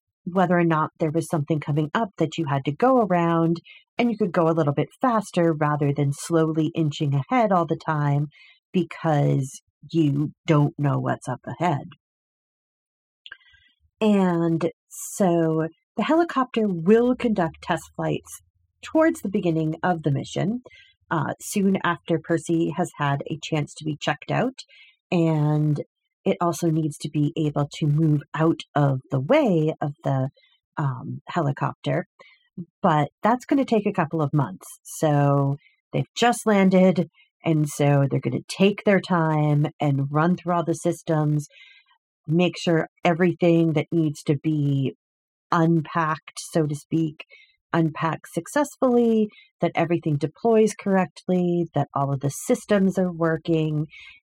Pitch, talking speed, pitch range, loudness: 165 Hz, 145 wpm, 150-190 Hz, -23 LUFS